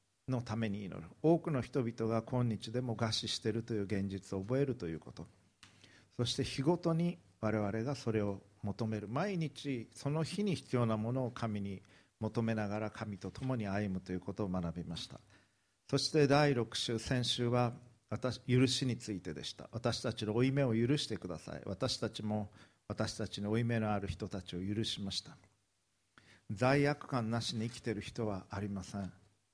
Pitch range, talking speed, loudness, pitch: 100-125 Hz, 330 characters per minute, -36 LUFS, 110 Hz